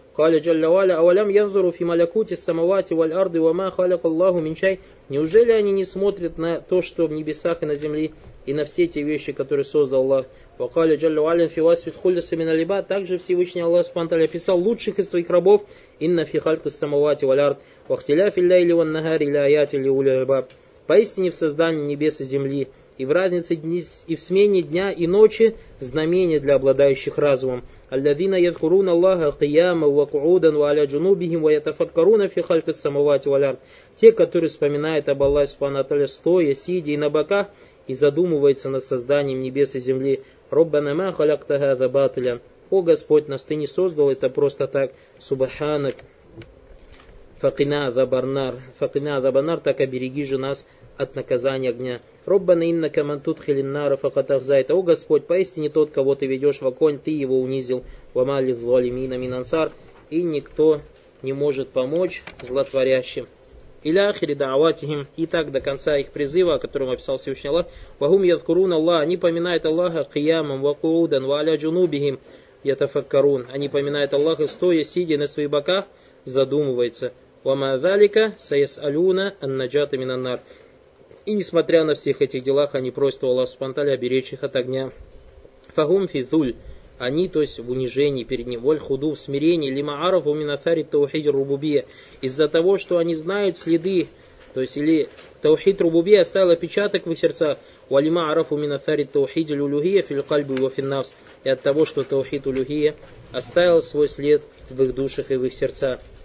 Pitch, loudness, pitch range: 150 Hz, -21 LUFS, 140-175 Hz